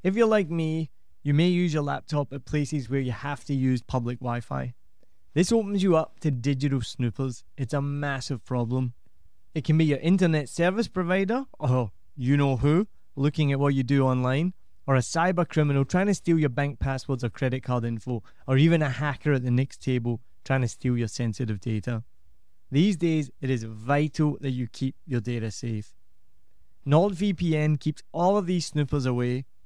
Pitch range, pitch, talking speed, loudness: 120-155 Hz, 140 Hz, 190 wpm, -26 LUFS